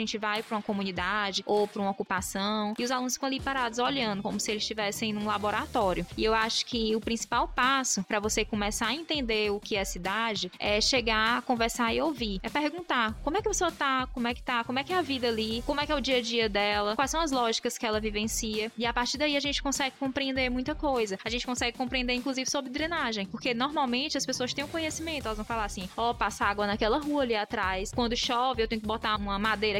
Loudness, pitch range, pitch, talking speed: -29 LUFS, 215-265 Hz, 235 Hz, 250 wpm